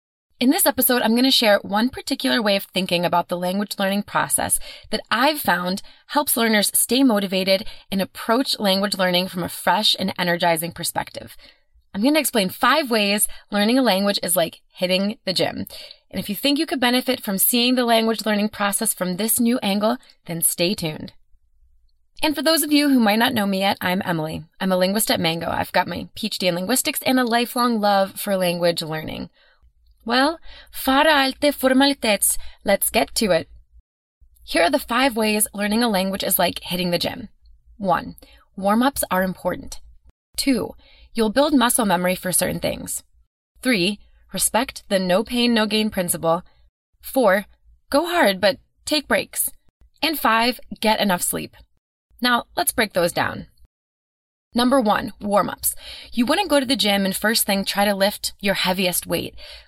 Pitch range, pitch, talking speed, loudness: 180-250 Hz, 205 Hz, 175 wpm, -20 LUFS